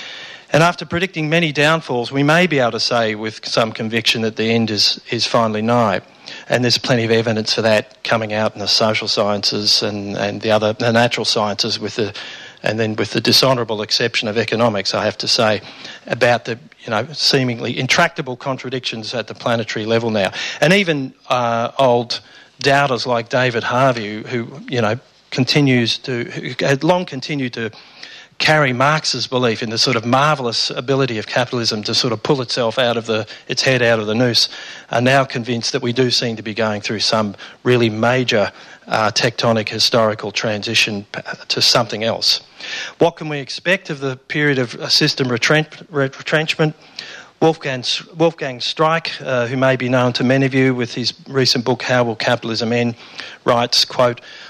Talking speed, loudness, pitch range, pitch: 180 wpm, -17 LUFS, 115-135 Hz, 120 Hz